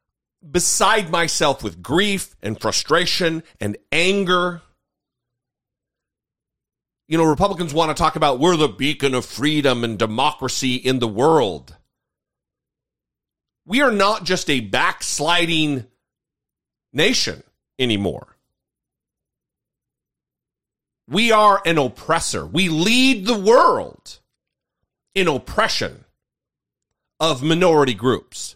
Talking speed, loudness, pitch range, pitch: 95 wpm, -18 LUFS, 130-180 Hz, 155 Hz